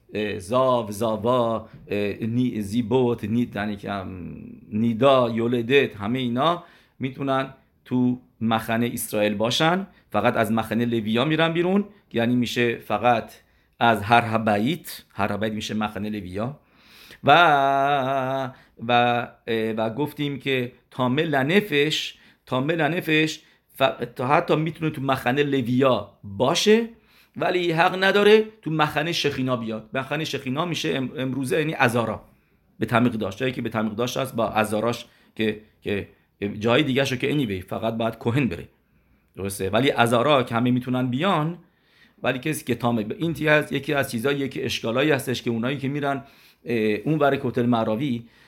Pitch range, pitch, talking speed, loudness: 115-140 Hz, 125 Hz, 130 wpm, -23 LUFS